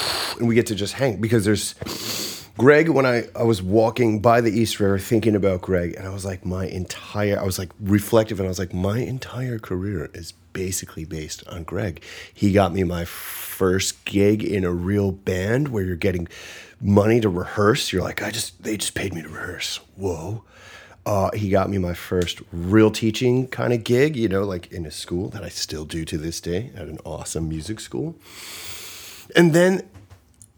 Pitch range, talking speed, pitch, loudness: 90-110 Hz, 200 wpm, 100 Hz, -22 LUFS